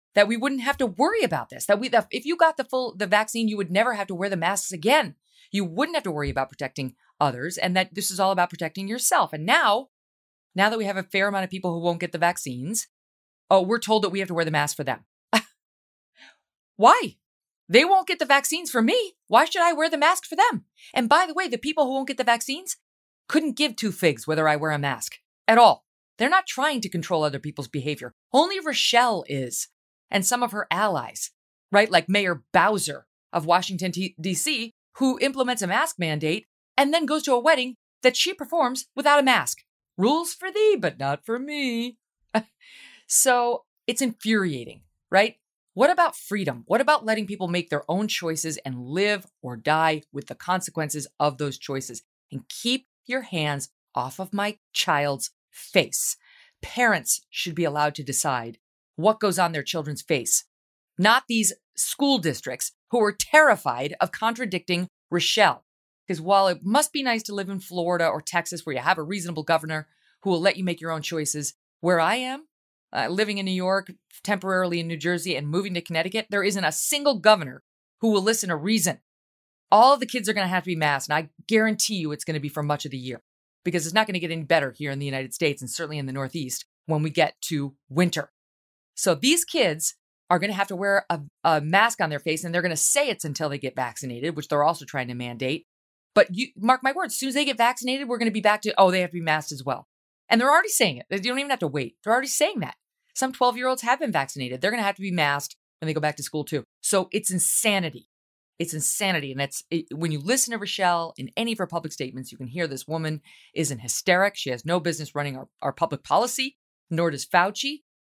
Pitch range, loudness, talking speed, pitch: 155-235 Hz, -24 LUFS, 225 wpm, 185 Hz